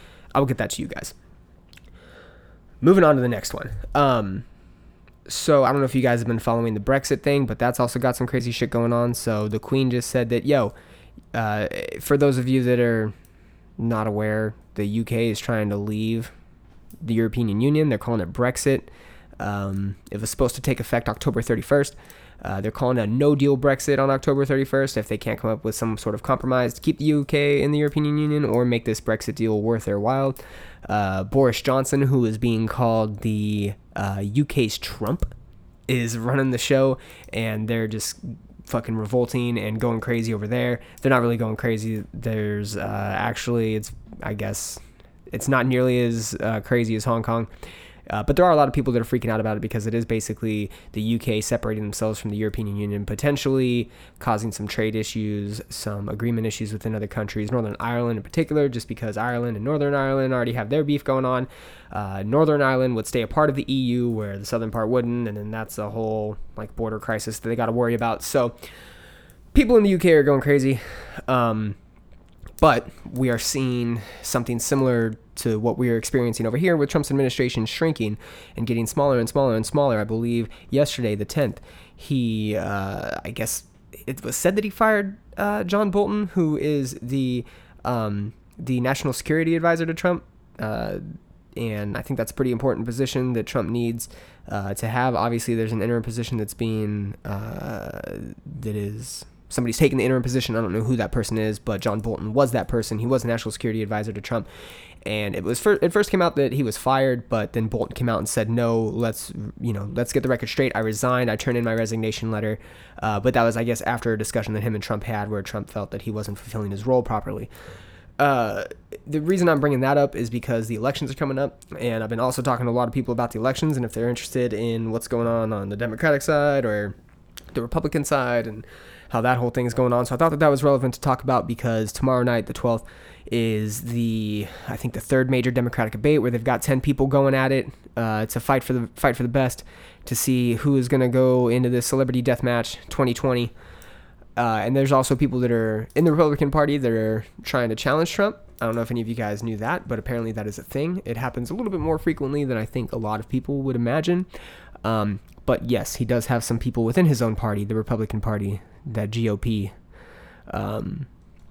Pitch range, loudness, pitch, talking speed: 110-130 Hz, -23 LUFS, 120 Hz, 215 wpm